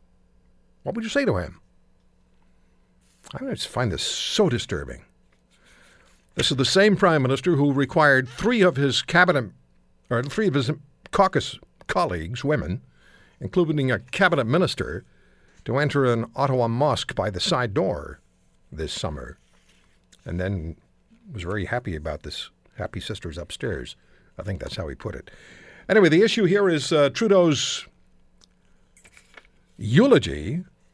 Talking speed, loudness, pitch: 140 wpm, -23 LUFS, 140 Hz